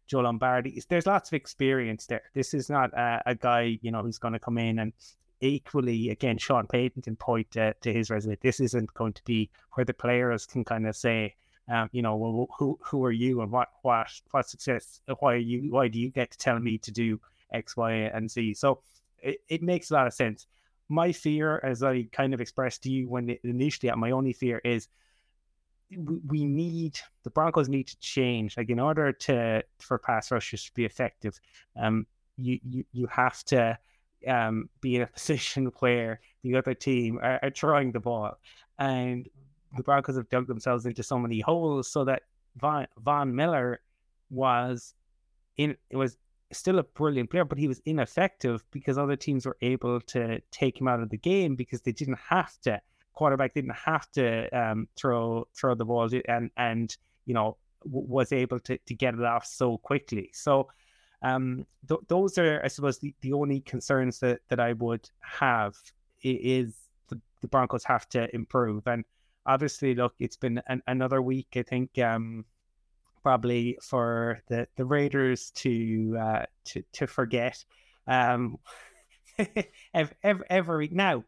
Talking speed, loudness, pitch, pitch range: 180 wpm, -29 LUFS, 125 Hz, 115-135 Hz